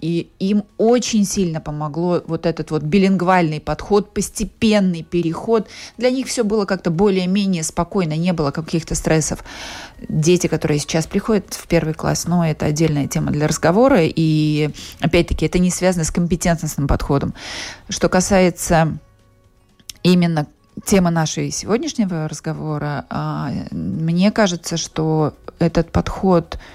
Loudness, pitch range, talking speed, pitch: -18 LUFS, 155-195 Hz, 130 wpm, 170 Hz